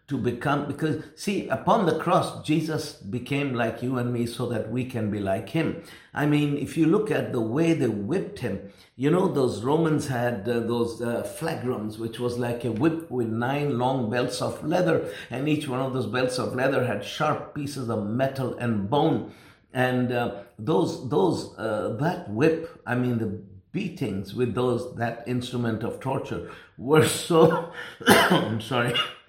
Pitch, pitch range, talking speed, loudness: 125 Hz, 120-150 Hz, 180 wpm, -26 LUFS